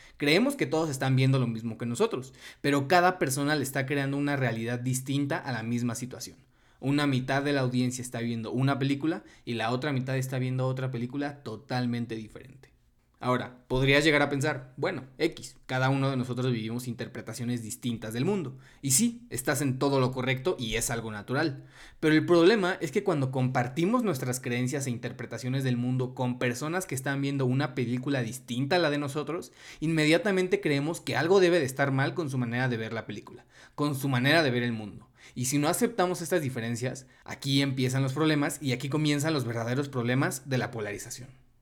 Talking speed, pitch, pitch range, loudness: 195 wpm, 130 Hz, 125-145 Hz, -28 LUFS